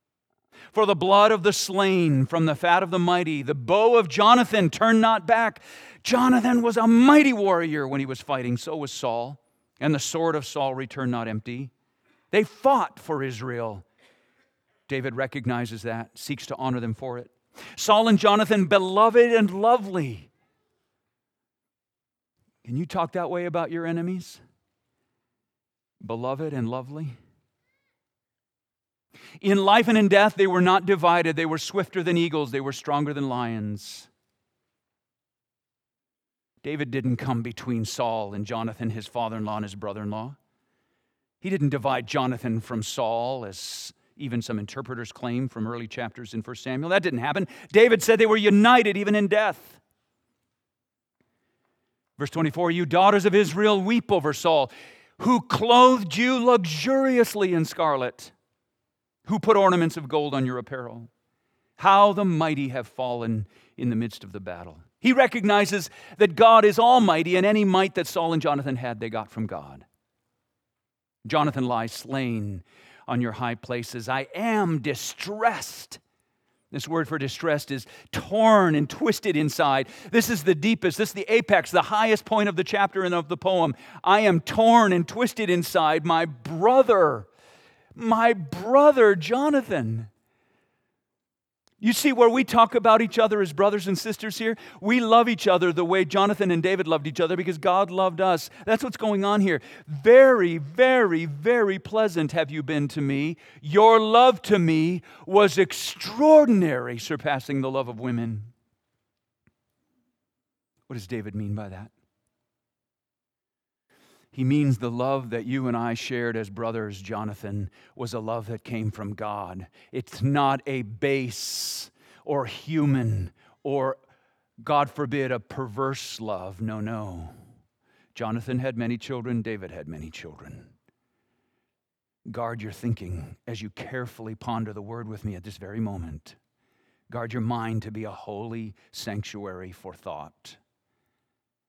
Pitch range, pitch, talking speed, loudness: 120-200 Hz, 145 Hz, 150 wpm, -23 LUFS